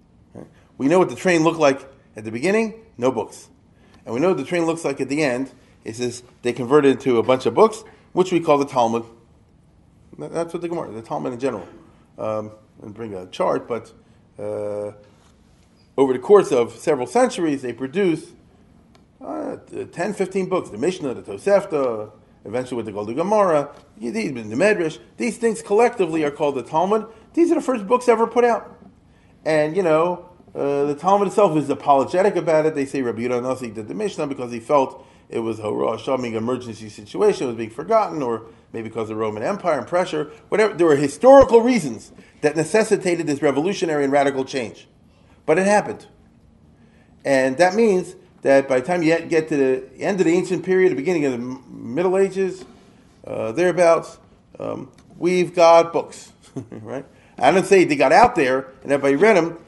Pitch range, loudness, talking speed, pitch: 125-185 Hz, -20 LUFS, 190 wpm, 150 Hz